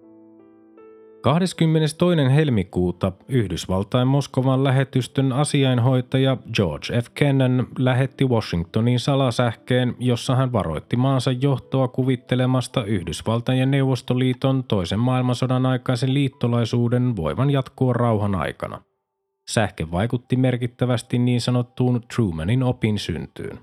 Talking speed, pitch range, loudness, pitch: 95 wpm, 110-130 Hz, -21 LUFS, 125 Hz